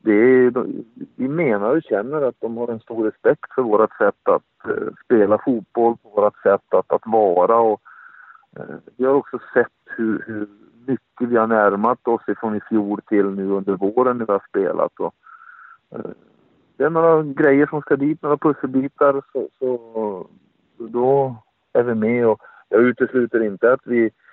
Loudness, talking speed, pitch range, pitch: -19 LUFS, 170 wpm, 110-145 Hz, 125 Hz